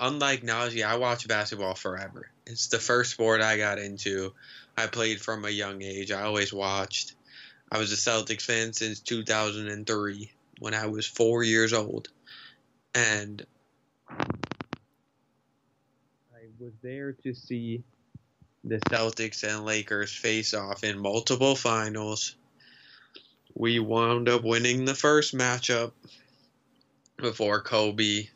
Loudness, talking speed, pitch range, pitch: -27 LUFS, 125 wpm, 105-120 Hz, 110 Hz